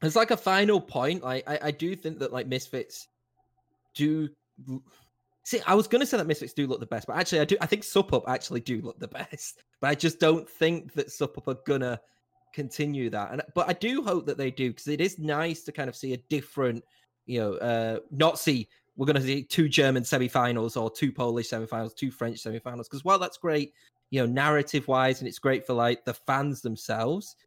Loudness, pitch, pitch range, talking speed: -28 LUFS, 140 Hz, 125-160 Hz, 225 wpm